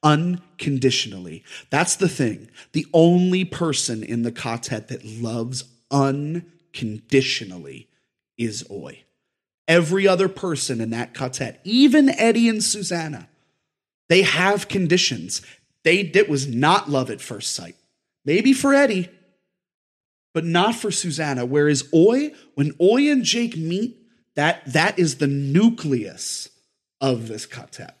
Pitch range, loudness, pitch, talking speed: 130-190 Hz, -20 LUFS, 160 Hz, 125 wpm